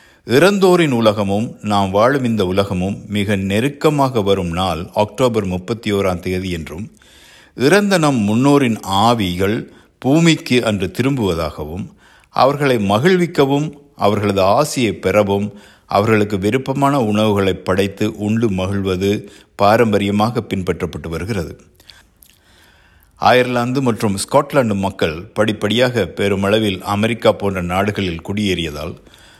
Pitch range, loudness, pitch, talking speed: 95-120 Hz, -16 LUFS, 105 Hz, 90 wpm